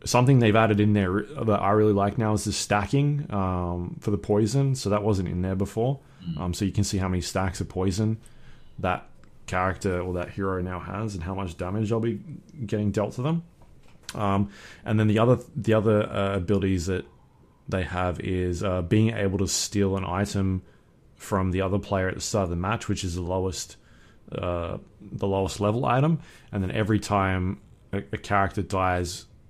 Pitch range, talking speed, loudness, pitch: 95-110 Hz, 195 wpm, -26 LUFS, 100 Hz